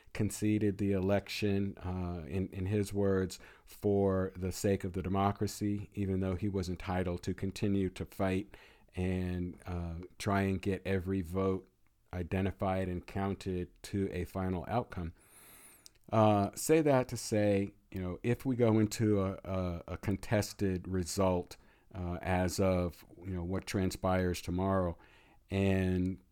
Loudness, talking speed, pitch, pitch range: -34 LUFS, 140 wpm, 95 Hz, 90-100 Hz